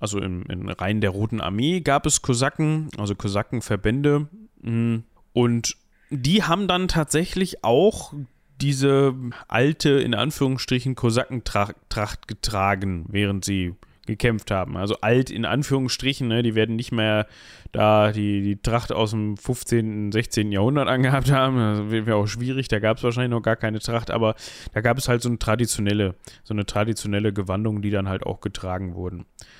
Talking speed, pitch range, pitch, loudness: 160 wpm, 105-130 Hz, 115 Hz, -23 LUFS